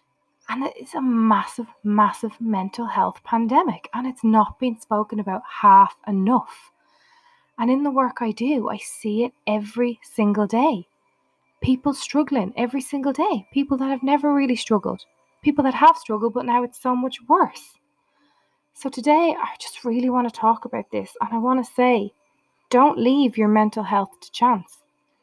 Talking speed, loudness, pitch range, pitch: 170 wpm, -21 LUFS, 220-275 Hz, 245 Hz